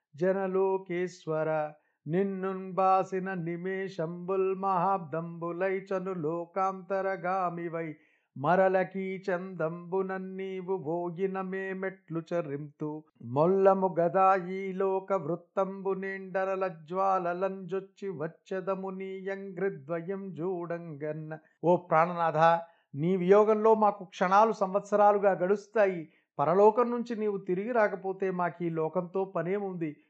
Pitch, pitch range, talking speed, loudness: 190 Hz, 170-195 Hz, 80 wpm, -30 LUFS